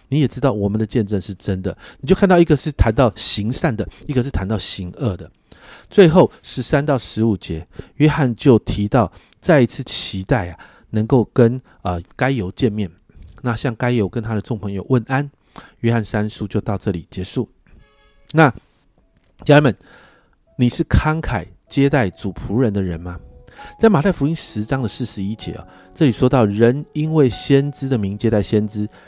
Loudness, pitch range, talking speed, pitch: -18 LUFS, 100-135 Hz, 260 characters per minute, 115 Hz